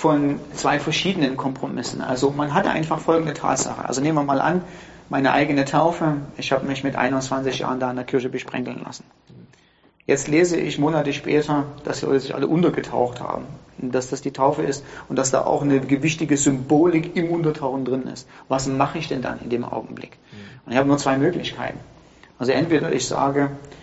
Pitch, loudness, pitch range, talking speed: 140 Hz, -22 LUFS, 135-150 Hz, 190 wpm